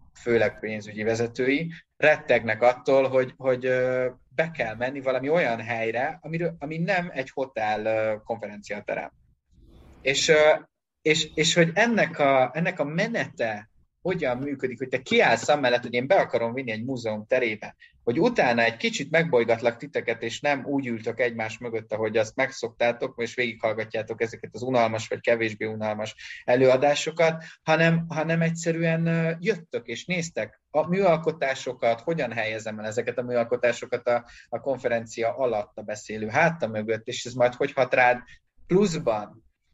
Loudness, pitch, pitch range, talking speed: -25 LUFS, 125 Hz, 115-155 Hz, 145 wpm